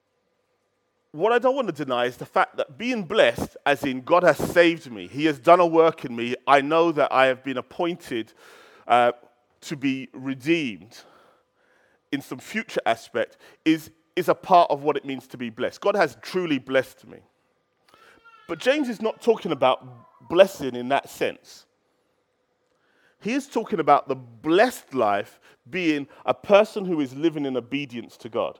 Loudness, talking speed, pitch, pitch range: -23 LUFS, 175 wpm, 160 Hz, 130-200 Hz